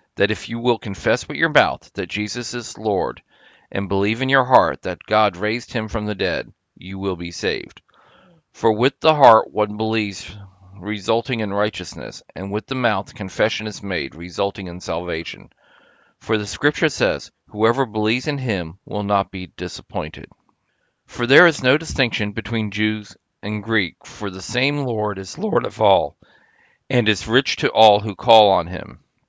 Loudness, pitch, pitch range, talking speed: -20 LUFS, 105 Hz, 95-115 Hz, 175 wpm